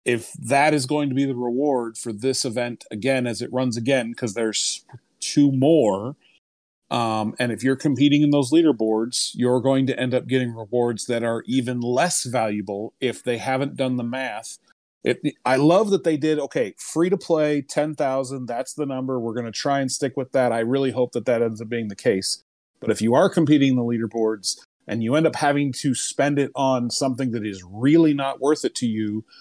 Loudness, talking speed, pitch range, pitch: -22 LUFS, 215 wpm, 115-140 Hz, 130 Hz